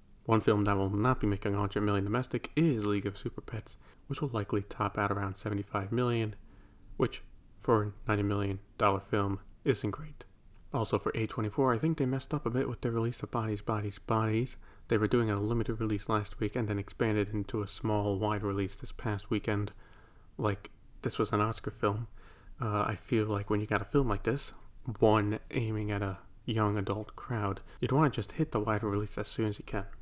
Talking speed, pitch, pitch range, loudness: 210 wpm, 105 Hz, 100-115 Hz, -32 LUFS